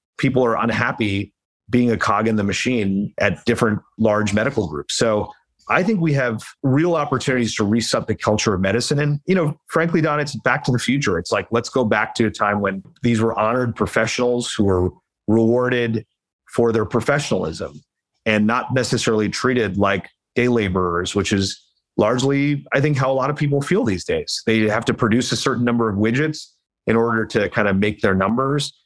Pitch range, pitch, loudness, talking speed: 105-135 Hz, 115 Hz, -19 LUFS, 195 wpm